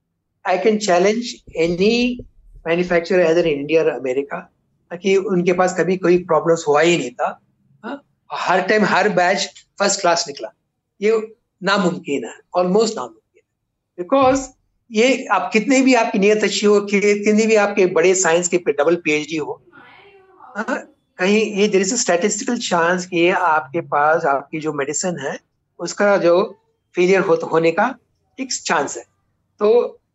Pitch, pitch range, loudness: 185 Hz, 165-215 Hz, -17 LUFS